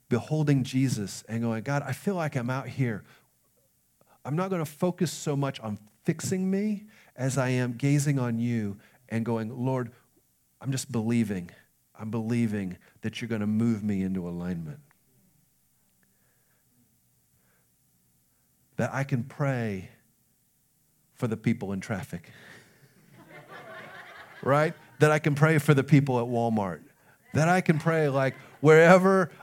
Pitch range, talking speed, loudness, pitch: 110-150 Hz, 140 wpm, -27 LUFS, 125 Hz